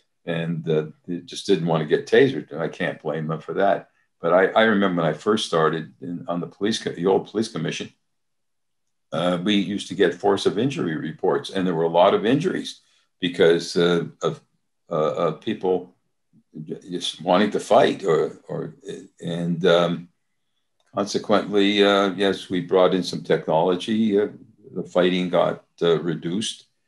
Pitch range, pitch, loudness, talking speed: 85-95 Hz, 90 Hz, -22 LUFS, 165 wpm